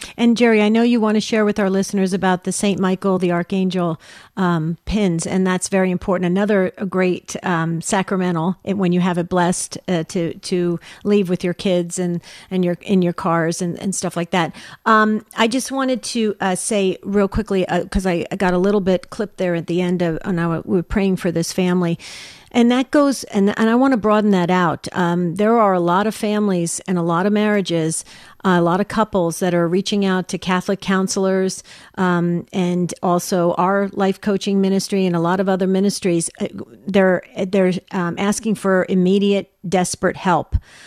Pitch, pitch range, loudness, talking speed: 185 Hz, 175-200 Hz, -18 LUFS, 195 wpm